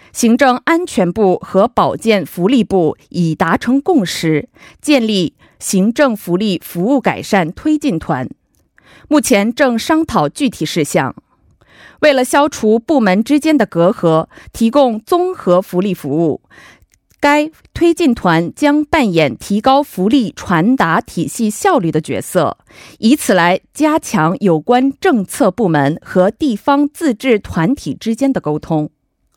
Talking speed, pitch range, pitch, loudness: 205 characters per minute, 180-280 Hz, 225 Hz, -14 LUFS